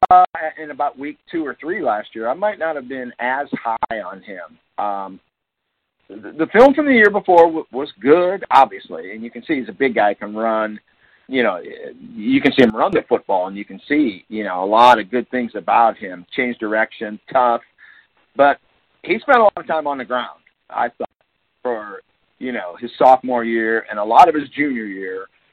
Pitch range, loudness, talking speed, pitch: 110-165 Hz, -17 LUFS, 210 wpm, 130 Hz